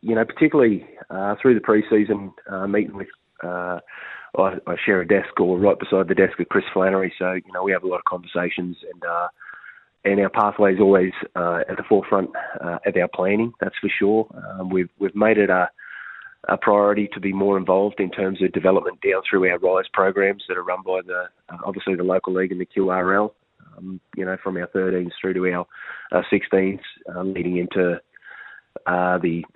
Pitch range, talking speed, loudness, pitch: 90-100 Hz, 200 wpm, -21 LUFS, 95 Hz